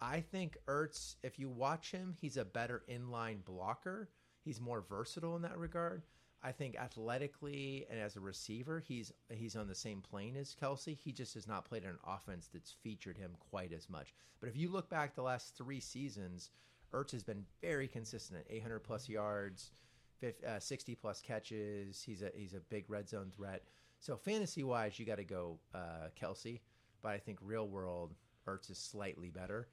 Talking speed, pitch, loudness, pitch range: 190 wpm, 115 Hz, -46 LUFS, 100-135 Hz